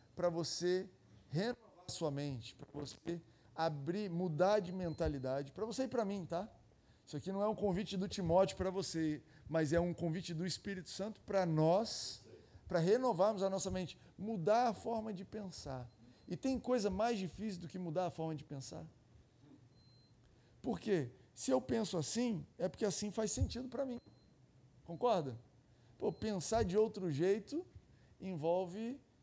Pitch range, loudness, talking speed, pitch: 145-205 Hz, -39 LUFS, 160 wpm, 180 Hz